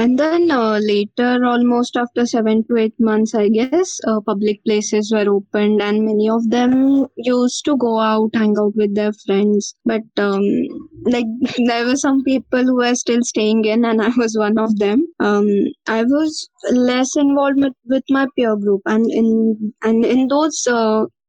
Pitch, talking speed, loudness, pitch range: 230 Hz, 180 wpm, -16 LUFS, 215-255 Hz